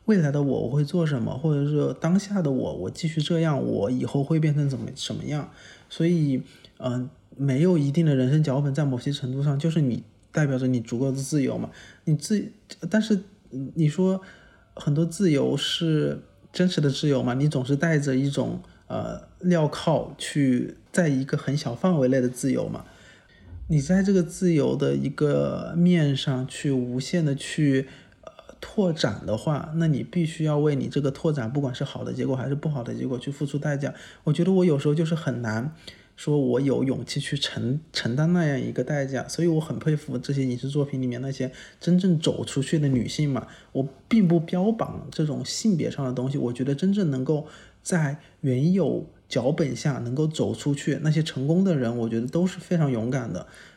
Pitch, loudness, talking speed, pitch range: 145 Hz, -25 LUFS, 280 characters per minute, 130-165 Hz